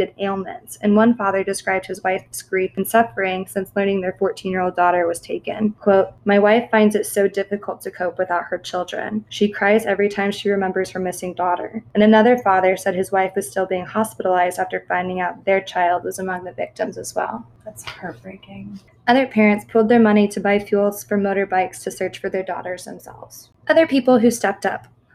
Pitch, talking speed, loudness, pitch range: 195 Hz, 195 wpm, -19 LUFS, 185-210 Hz